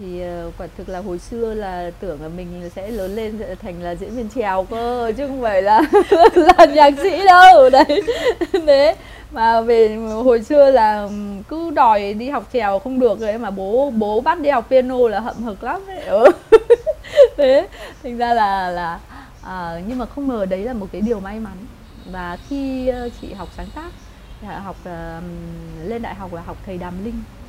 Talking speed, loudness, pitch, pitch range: 190 wpm, -15 LUFS, 225 Hz, 190-275 Hz